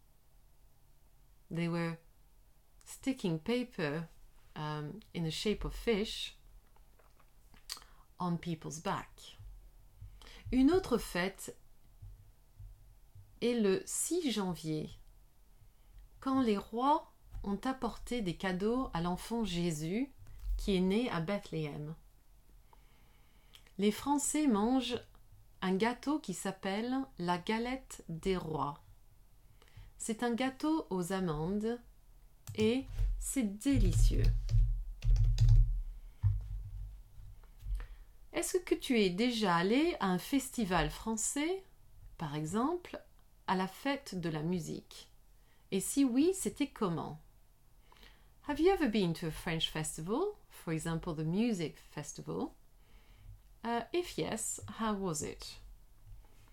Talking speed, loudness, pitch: 100 wpm, -35 LUFS, 175 Hz